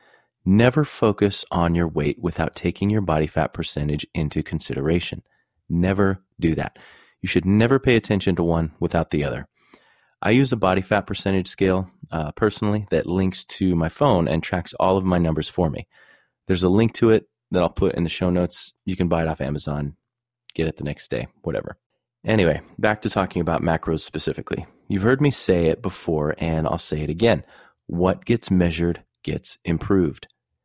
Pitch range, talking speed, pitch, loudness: 80-100 Hz, 185 wpm, 90 Hz, -22 LUFS